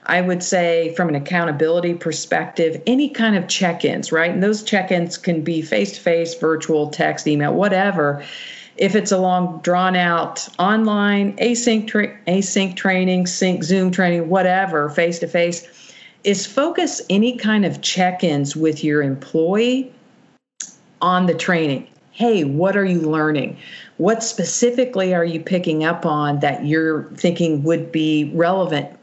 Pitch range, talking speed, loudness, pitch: 160-200 Hz, 140 wpm, -18 LUFS, 180 Hz